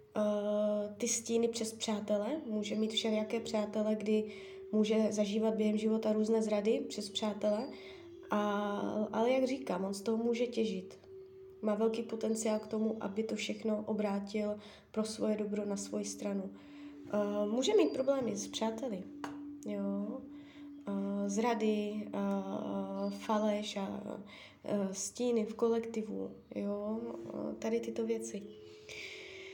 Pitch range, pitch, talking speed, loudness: 210-230 Hz, 215 Hz, 125 wpm, -35 LUFS